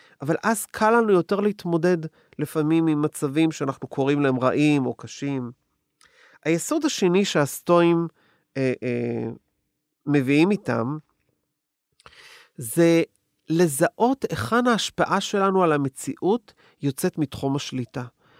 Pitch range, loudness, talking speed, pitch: 140-185 Hz, -23 LUFS, 105 wpm, 160 Hz